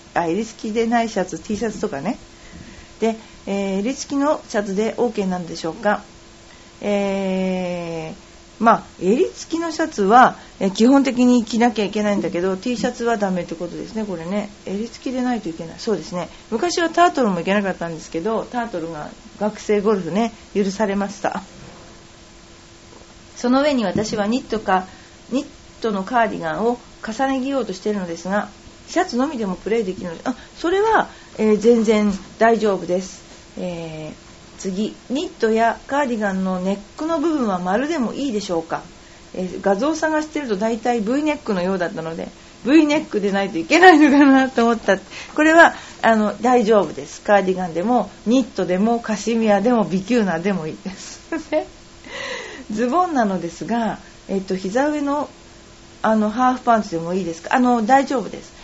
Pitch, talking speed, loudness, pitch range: 220 Hz, 355 characters per minute, -20 LUFS, 190-255 Hz